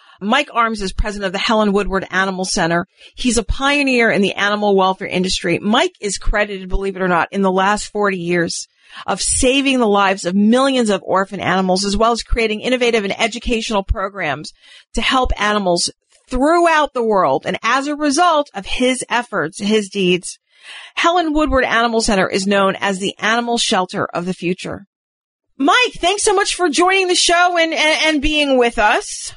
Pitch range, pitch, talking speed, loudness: 195-270 Hz, 220 Hz, 180 wpm, -16 LUFS